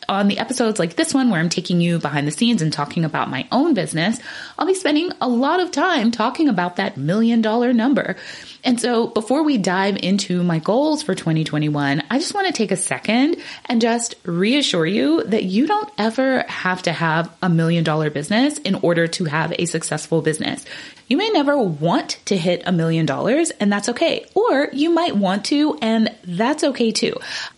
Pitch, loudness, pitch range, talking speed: 220 Hz, -19 LUFS, 175-275 Hz, 200 wpm